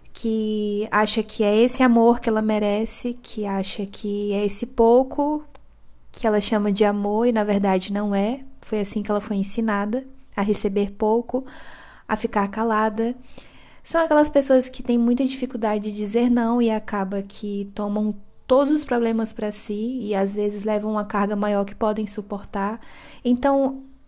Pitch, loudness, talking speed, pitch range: 215 Hz, -22 LUFS, 165 wpm, 205-245 Hz